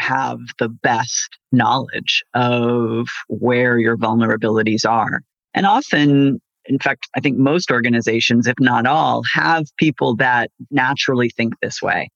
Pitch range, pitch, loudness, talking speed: 115-135 Hz, 120 Hz, -17 LUFS, 135 wpm